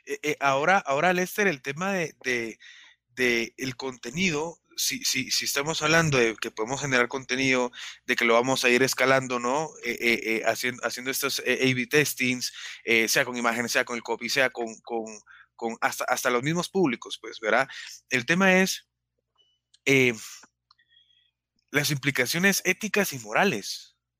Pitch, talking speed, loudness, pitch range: 130 Hz, 155 wpm, -25 LUFS, 120-150 Hz